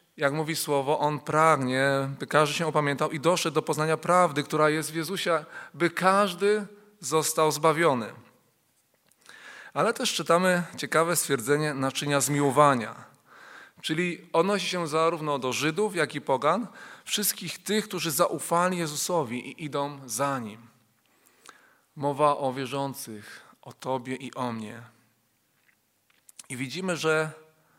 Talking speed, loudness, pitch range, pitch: 125 wpm, -26 LUFS, 140-170 Hz, 155 Hz